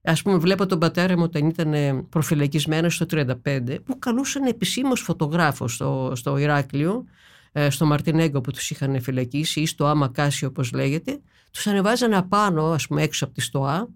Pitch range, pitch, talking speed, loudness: 140-180 Hz, 155 Hz, 170 wpm, -22 LUFS